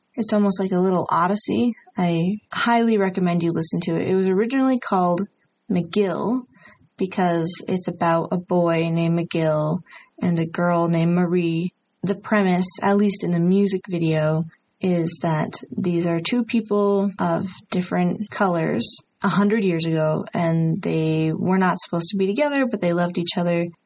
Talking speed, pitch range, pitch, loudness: 160 wpm, 170-200 Hz, 180 Hz, -22 LUFS